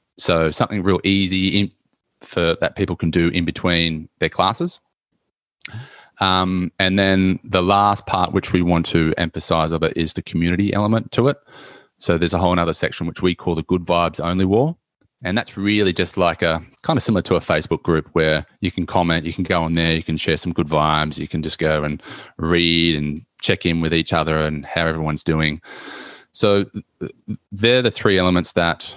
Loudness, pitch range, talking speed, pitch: -19 LUFS, 80-95 Hz, 200 wpm, 85 Hz